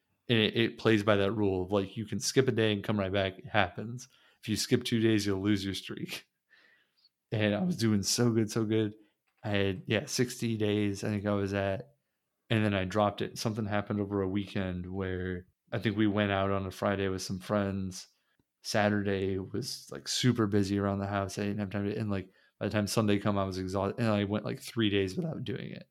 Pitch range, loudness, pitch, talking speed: 100-110 Hz, -31 LUFS, 105 Hz, 235 wpm